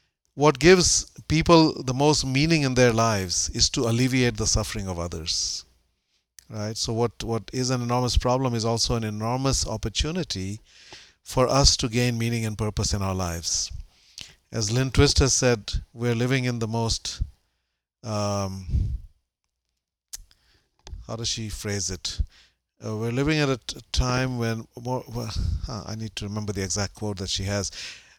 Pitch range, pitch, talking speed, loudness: 95-125 Hz, 110 Hz, 160 wpm, -24 LUFS